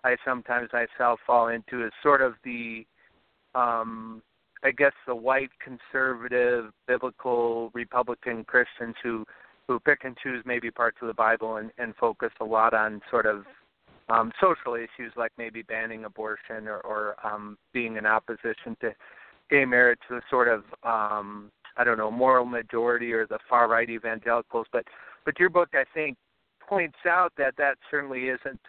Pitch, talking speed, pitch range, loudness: 120 Hz, 165 wpm, 110-130 Hz, -26 LUFS